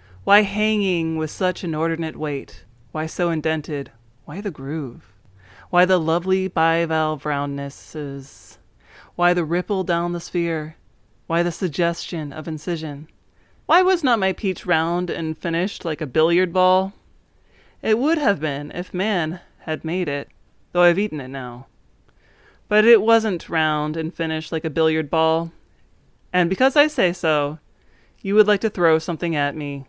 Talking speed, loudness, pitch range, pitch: 155 wpm, -21 LUFS, 150-180 Hz, 165 Hz